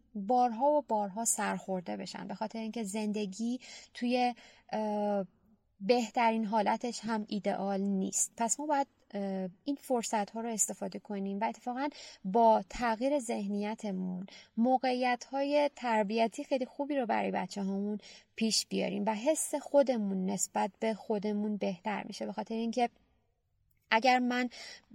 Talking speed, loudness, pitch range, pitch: 125 wpm, -33 LUFS, 205-245 Hz, 225 Hz